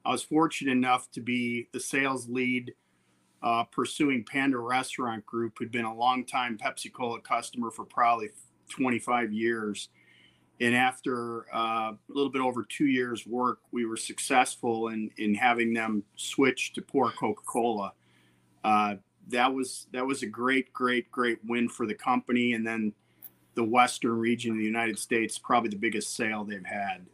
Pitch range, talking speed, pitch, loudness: 110-125 Hz, 160 wpm, 115 Hz, -29 LUFS